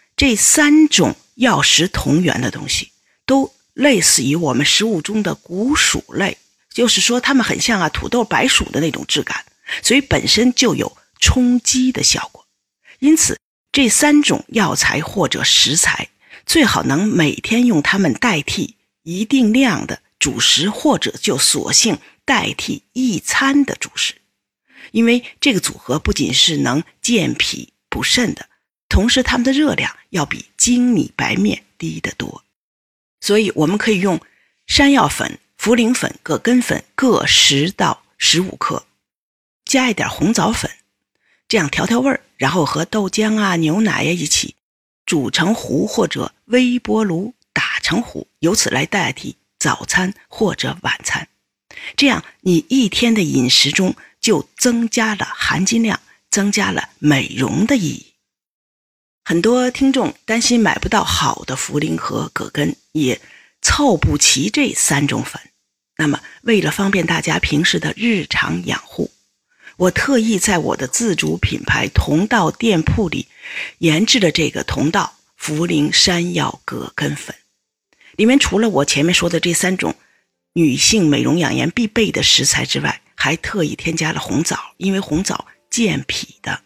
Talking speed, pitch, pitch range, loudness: 220 characters per minute, 220 Hz, 175-250 Hz, -16 LUFS